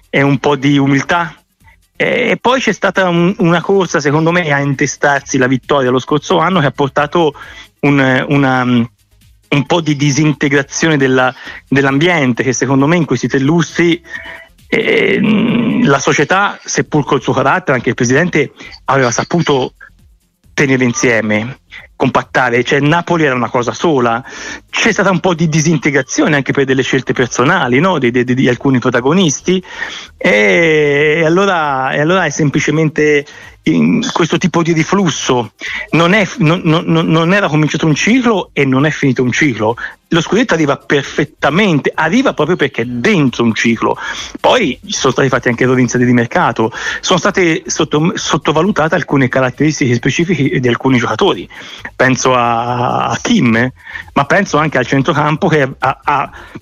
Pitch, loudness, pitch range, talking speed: 145 Hz, -12 LUFS, 130-170 Hz, 150 wpm